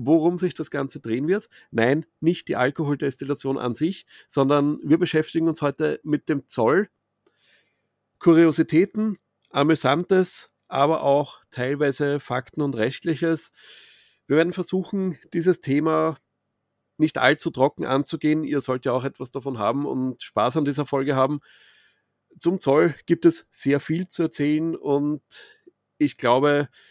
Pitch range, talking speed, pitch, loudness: 140-165 Hz, 135 wpm, 150 Hz, -23 LUFS